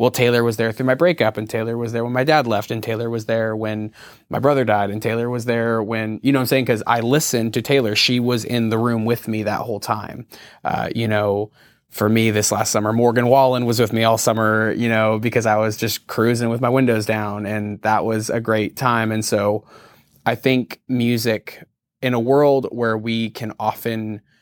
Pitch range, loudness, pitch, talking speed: 110-120 Hz, -19 LUFS, 115 Hz, 225 wpm